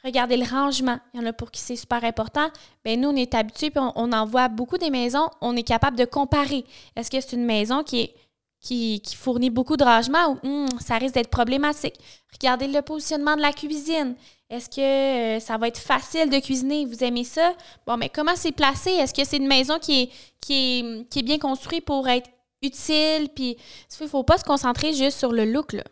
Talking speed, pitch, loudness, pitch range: 225 wpm, 265 Hz, -23 LUFS, 245-295 Hz